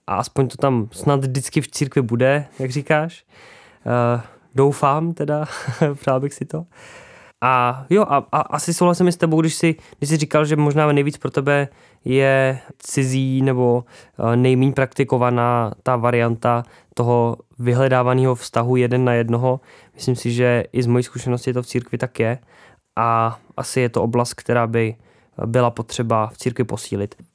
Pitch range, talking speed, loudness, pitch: 120-145 Hz, 160 wpm, -19 LUFS, 130 Hz